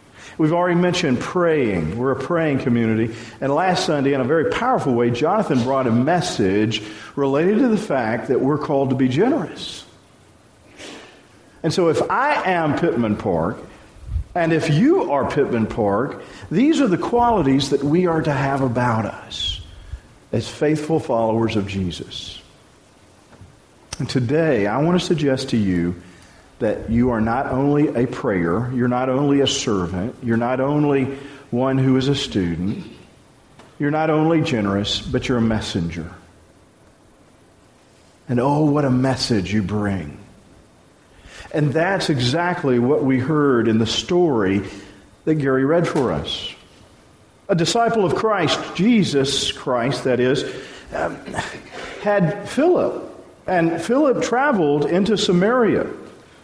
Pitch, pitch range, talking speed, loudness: 135 Hz, 110-160 Hz, 140 wpm, -19 LUFS